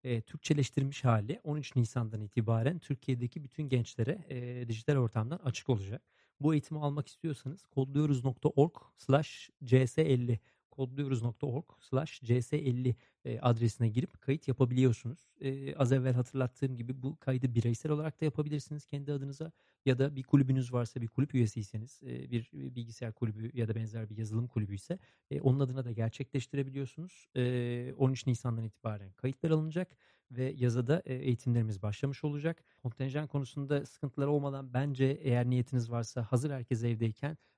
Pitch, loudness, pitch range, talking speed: 130 Hz, -34 LUFS, 120-145 Hz, 130 wpm